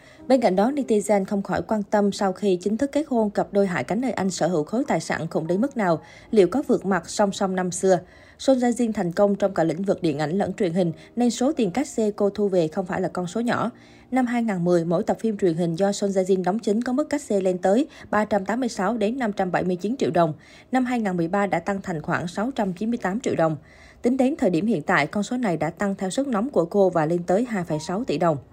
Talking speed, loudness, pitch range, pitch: 240 wpm, -23 LUFS, 180-225 Hz, 200 Hz